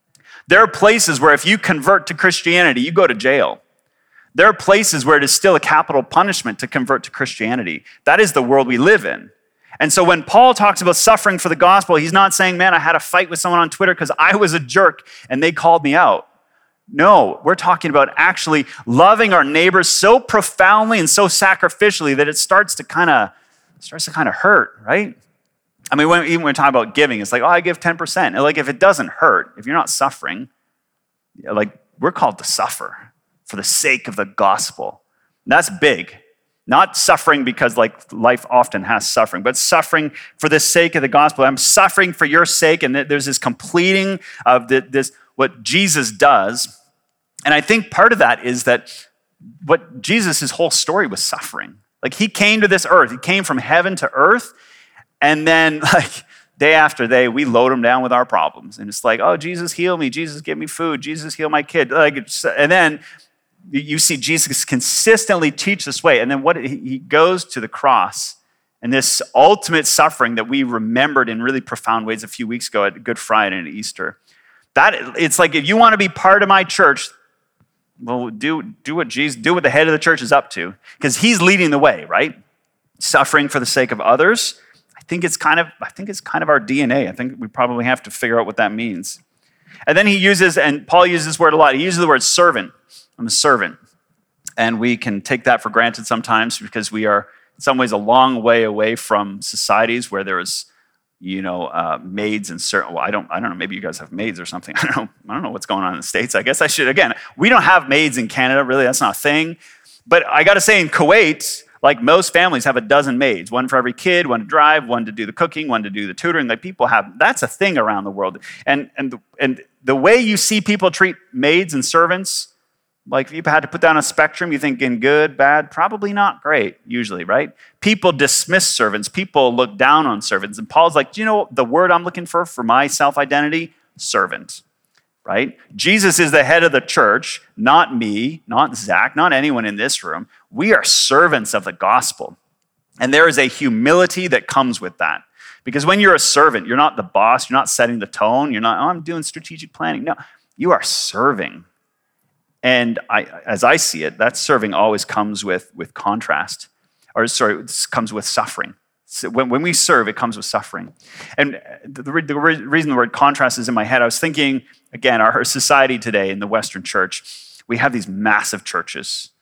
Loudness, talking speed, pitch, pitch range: -15 LUFS, 215 wpm, 155 Hz, 130-185 Hz